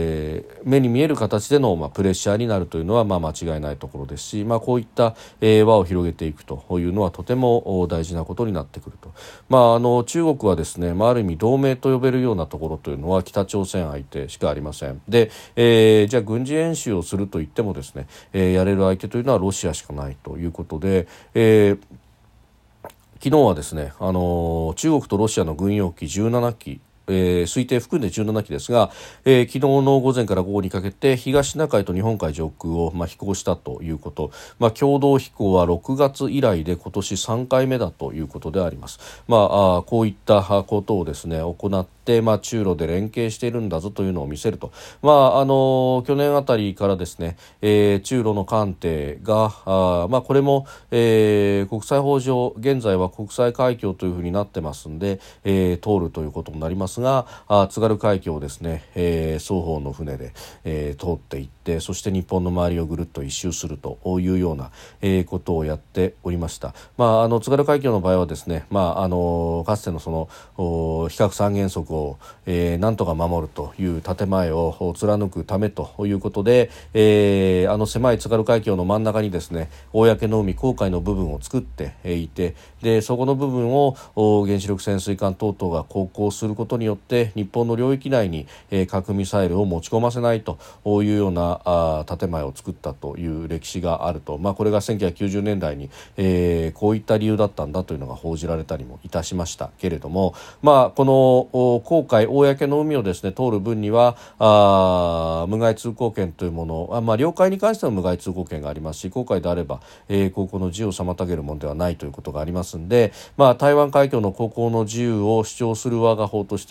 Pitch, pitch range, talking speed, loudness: 100 Hz, 85-115 Hz, 355 characters per minute, -21 LUFS